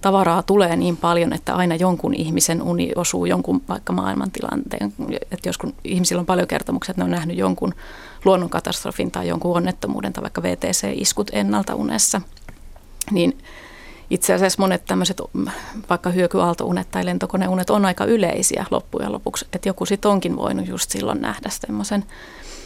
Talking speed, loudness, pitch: 150 wpm, -21 LUFS, 175 Hz